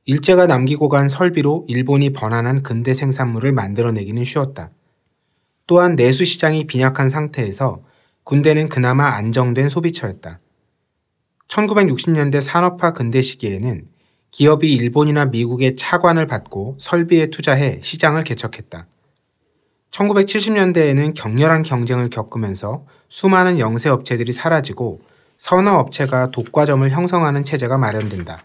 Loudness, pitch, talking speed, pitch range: -16 LUFS, 140 Hz, 305 characters per minute, 120-160 Hz